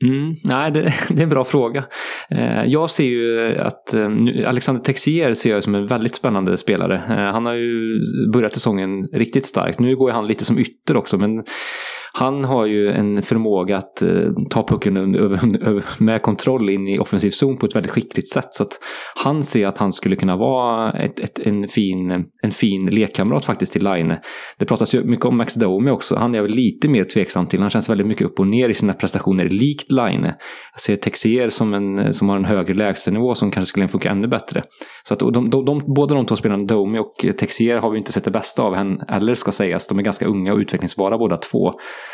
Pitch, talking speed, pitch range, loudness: 115 Hz, 215 wpm, 100-130 Hz, -18 LUFS